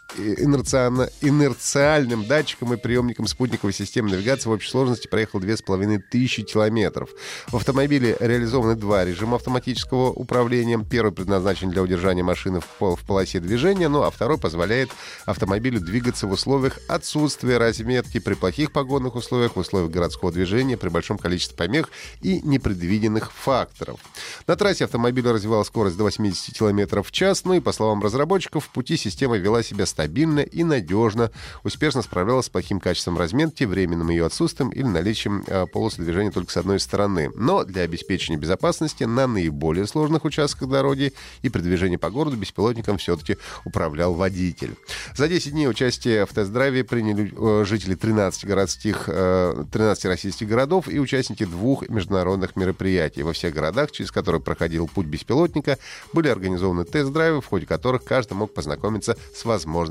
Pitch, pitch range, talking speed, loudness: 110 Hz, 95-130 Hz, 150 wpm, -22 LUFS